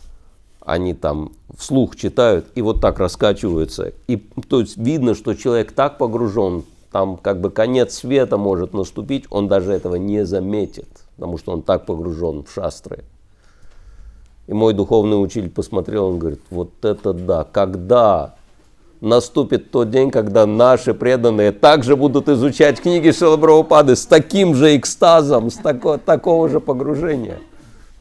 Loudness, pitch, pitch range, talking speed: -16 LUFS, 115 Hz, 95-145 Hz, 140 wpm